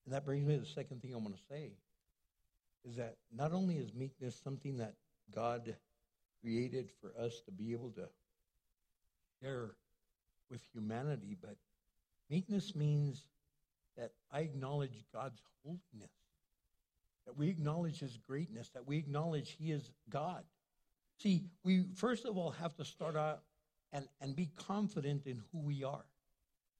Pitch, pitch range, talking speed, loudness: 135 Hz, 115-150 Hz, 150 wpm, -42 LUFS